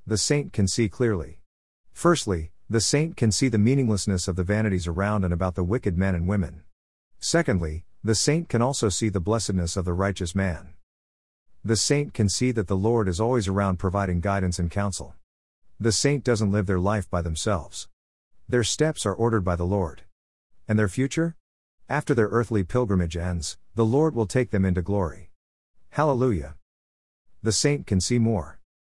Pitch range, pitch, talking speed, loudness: 90-115 Hz, 100 Hz, 175 wpm, -24 LUFS